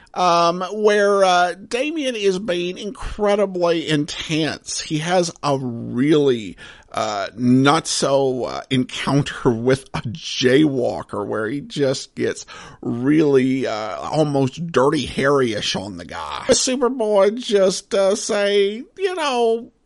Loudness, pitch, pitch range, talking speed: -19 LUFS, 175 Hz, 140-210 Hz, 115 wpm